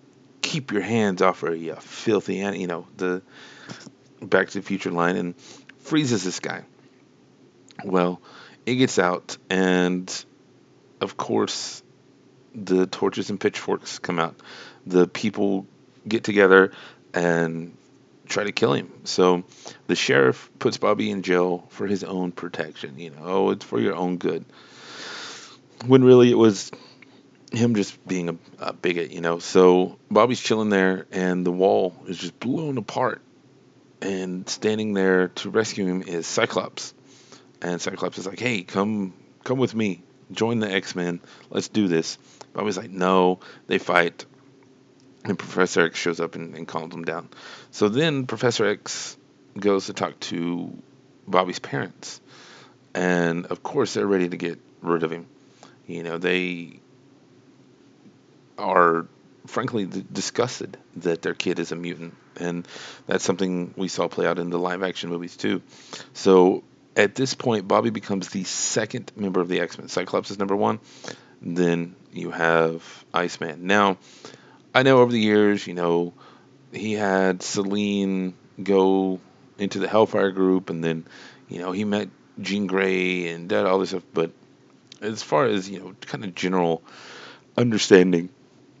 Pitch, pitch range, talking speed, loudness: 95 Hz, 90-105 Hz, 150 wpm, -23 LUFS